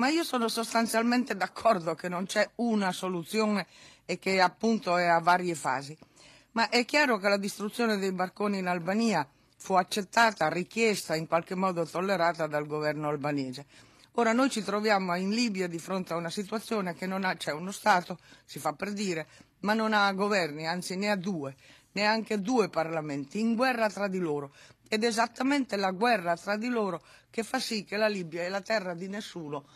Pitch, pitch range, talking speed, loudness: 190 Hz, 165-220 Hz, 190 wpm, -29 LUFS